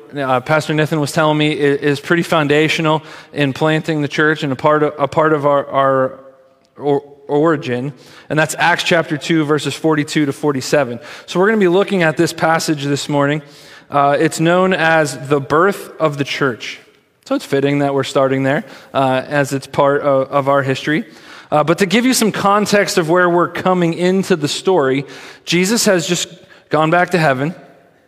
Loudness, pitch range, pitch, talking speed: -15 LUFS, 140-170 Hz, 150 Hz, 195 wpm